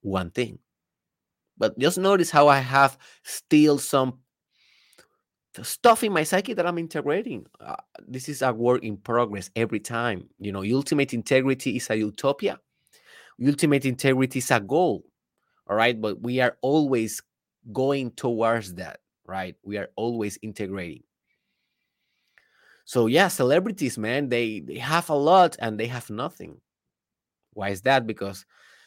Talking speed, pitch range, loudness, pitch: 145 wpm, 110-140 Hz, -24 LUFS, 125 Hz